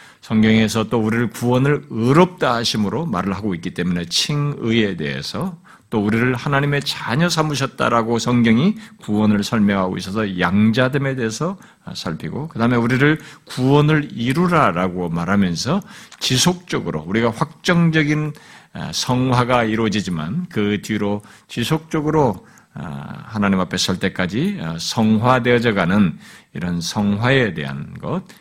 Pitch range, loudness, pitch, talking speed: 105-150 Hz, -19 LUFS, 120 Hz, 305 characters per minute